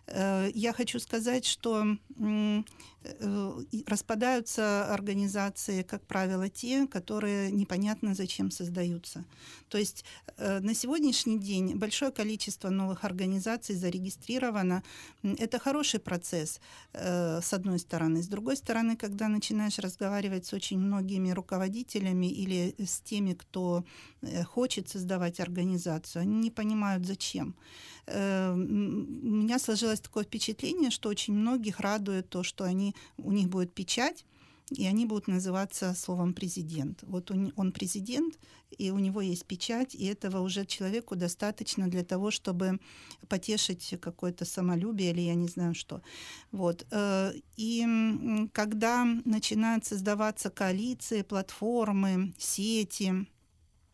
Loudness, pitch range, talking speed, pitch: -32 LUFS, 185-220 Hz, 115 wpm, 200 Hz